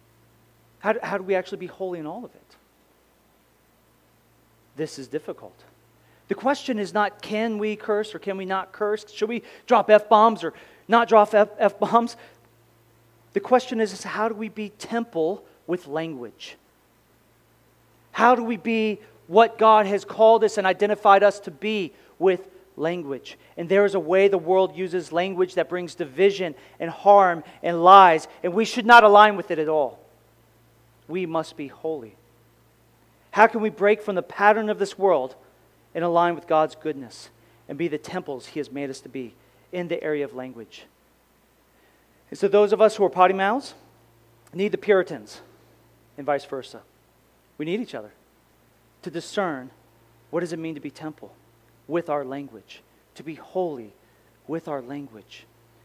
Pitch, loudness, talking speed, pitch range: 175 Hz, -21 LUFS, 170 wpm, 130-205 Hz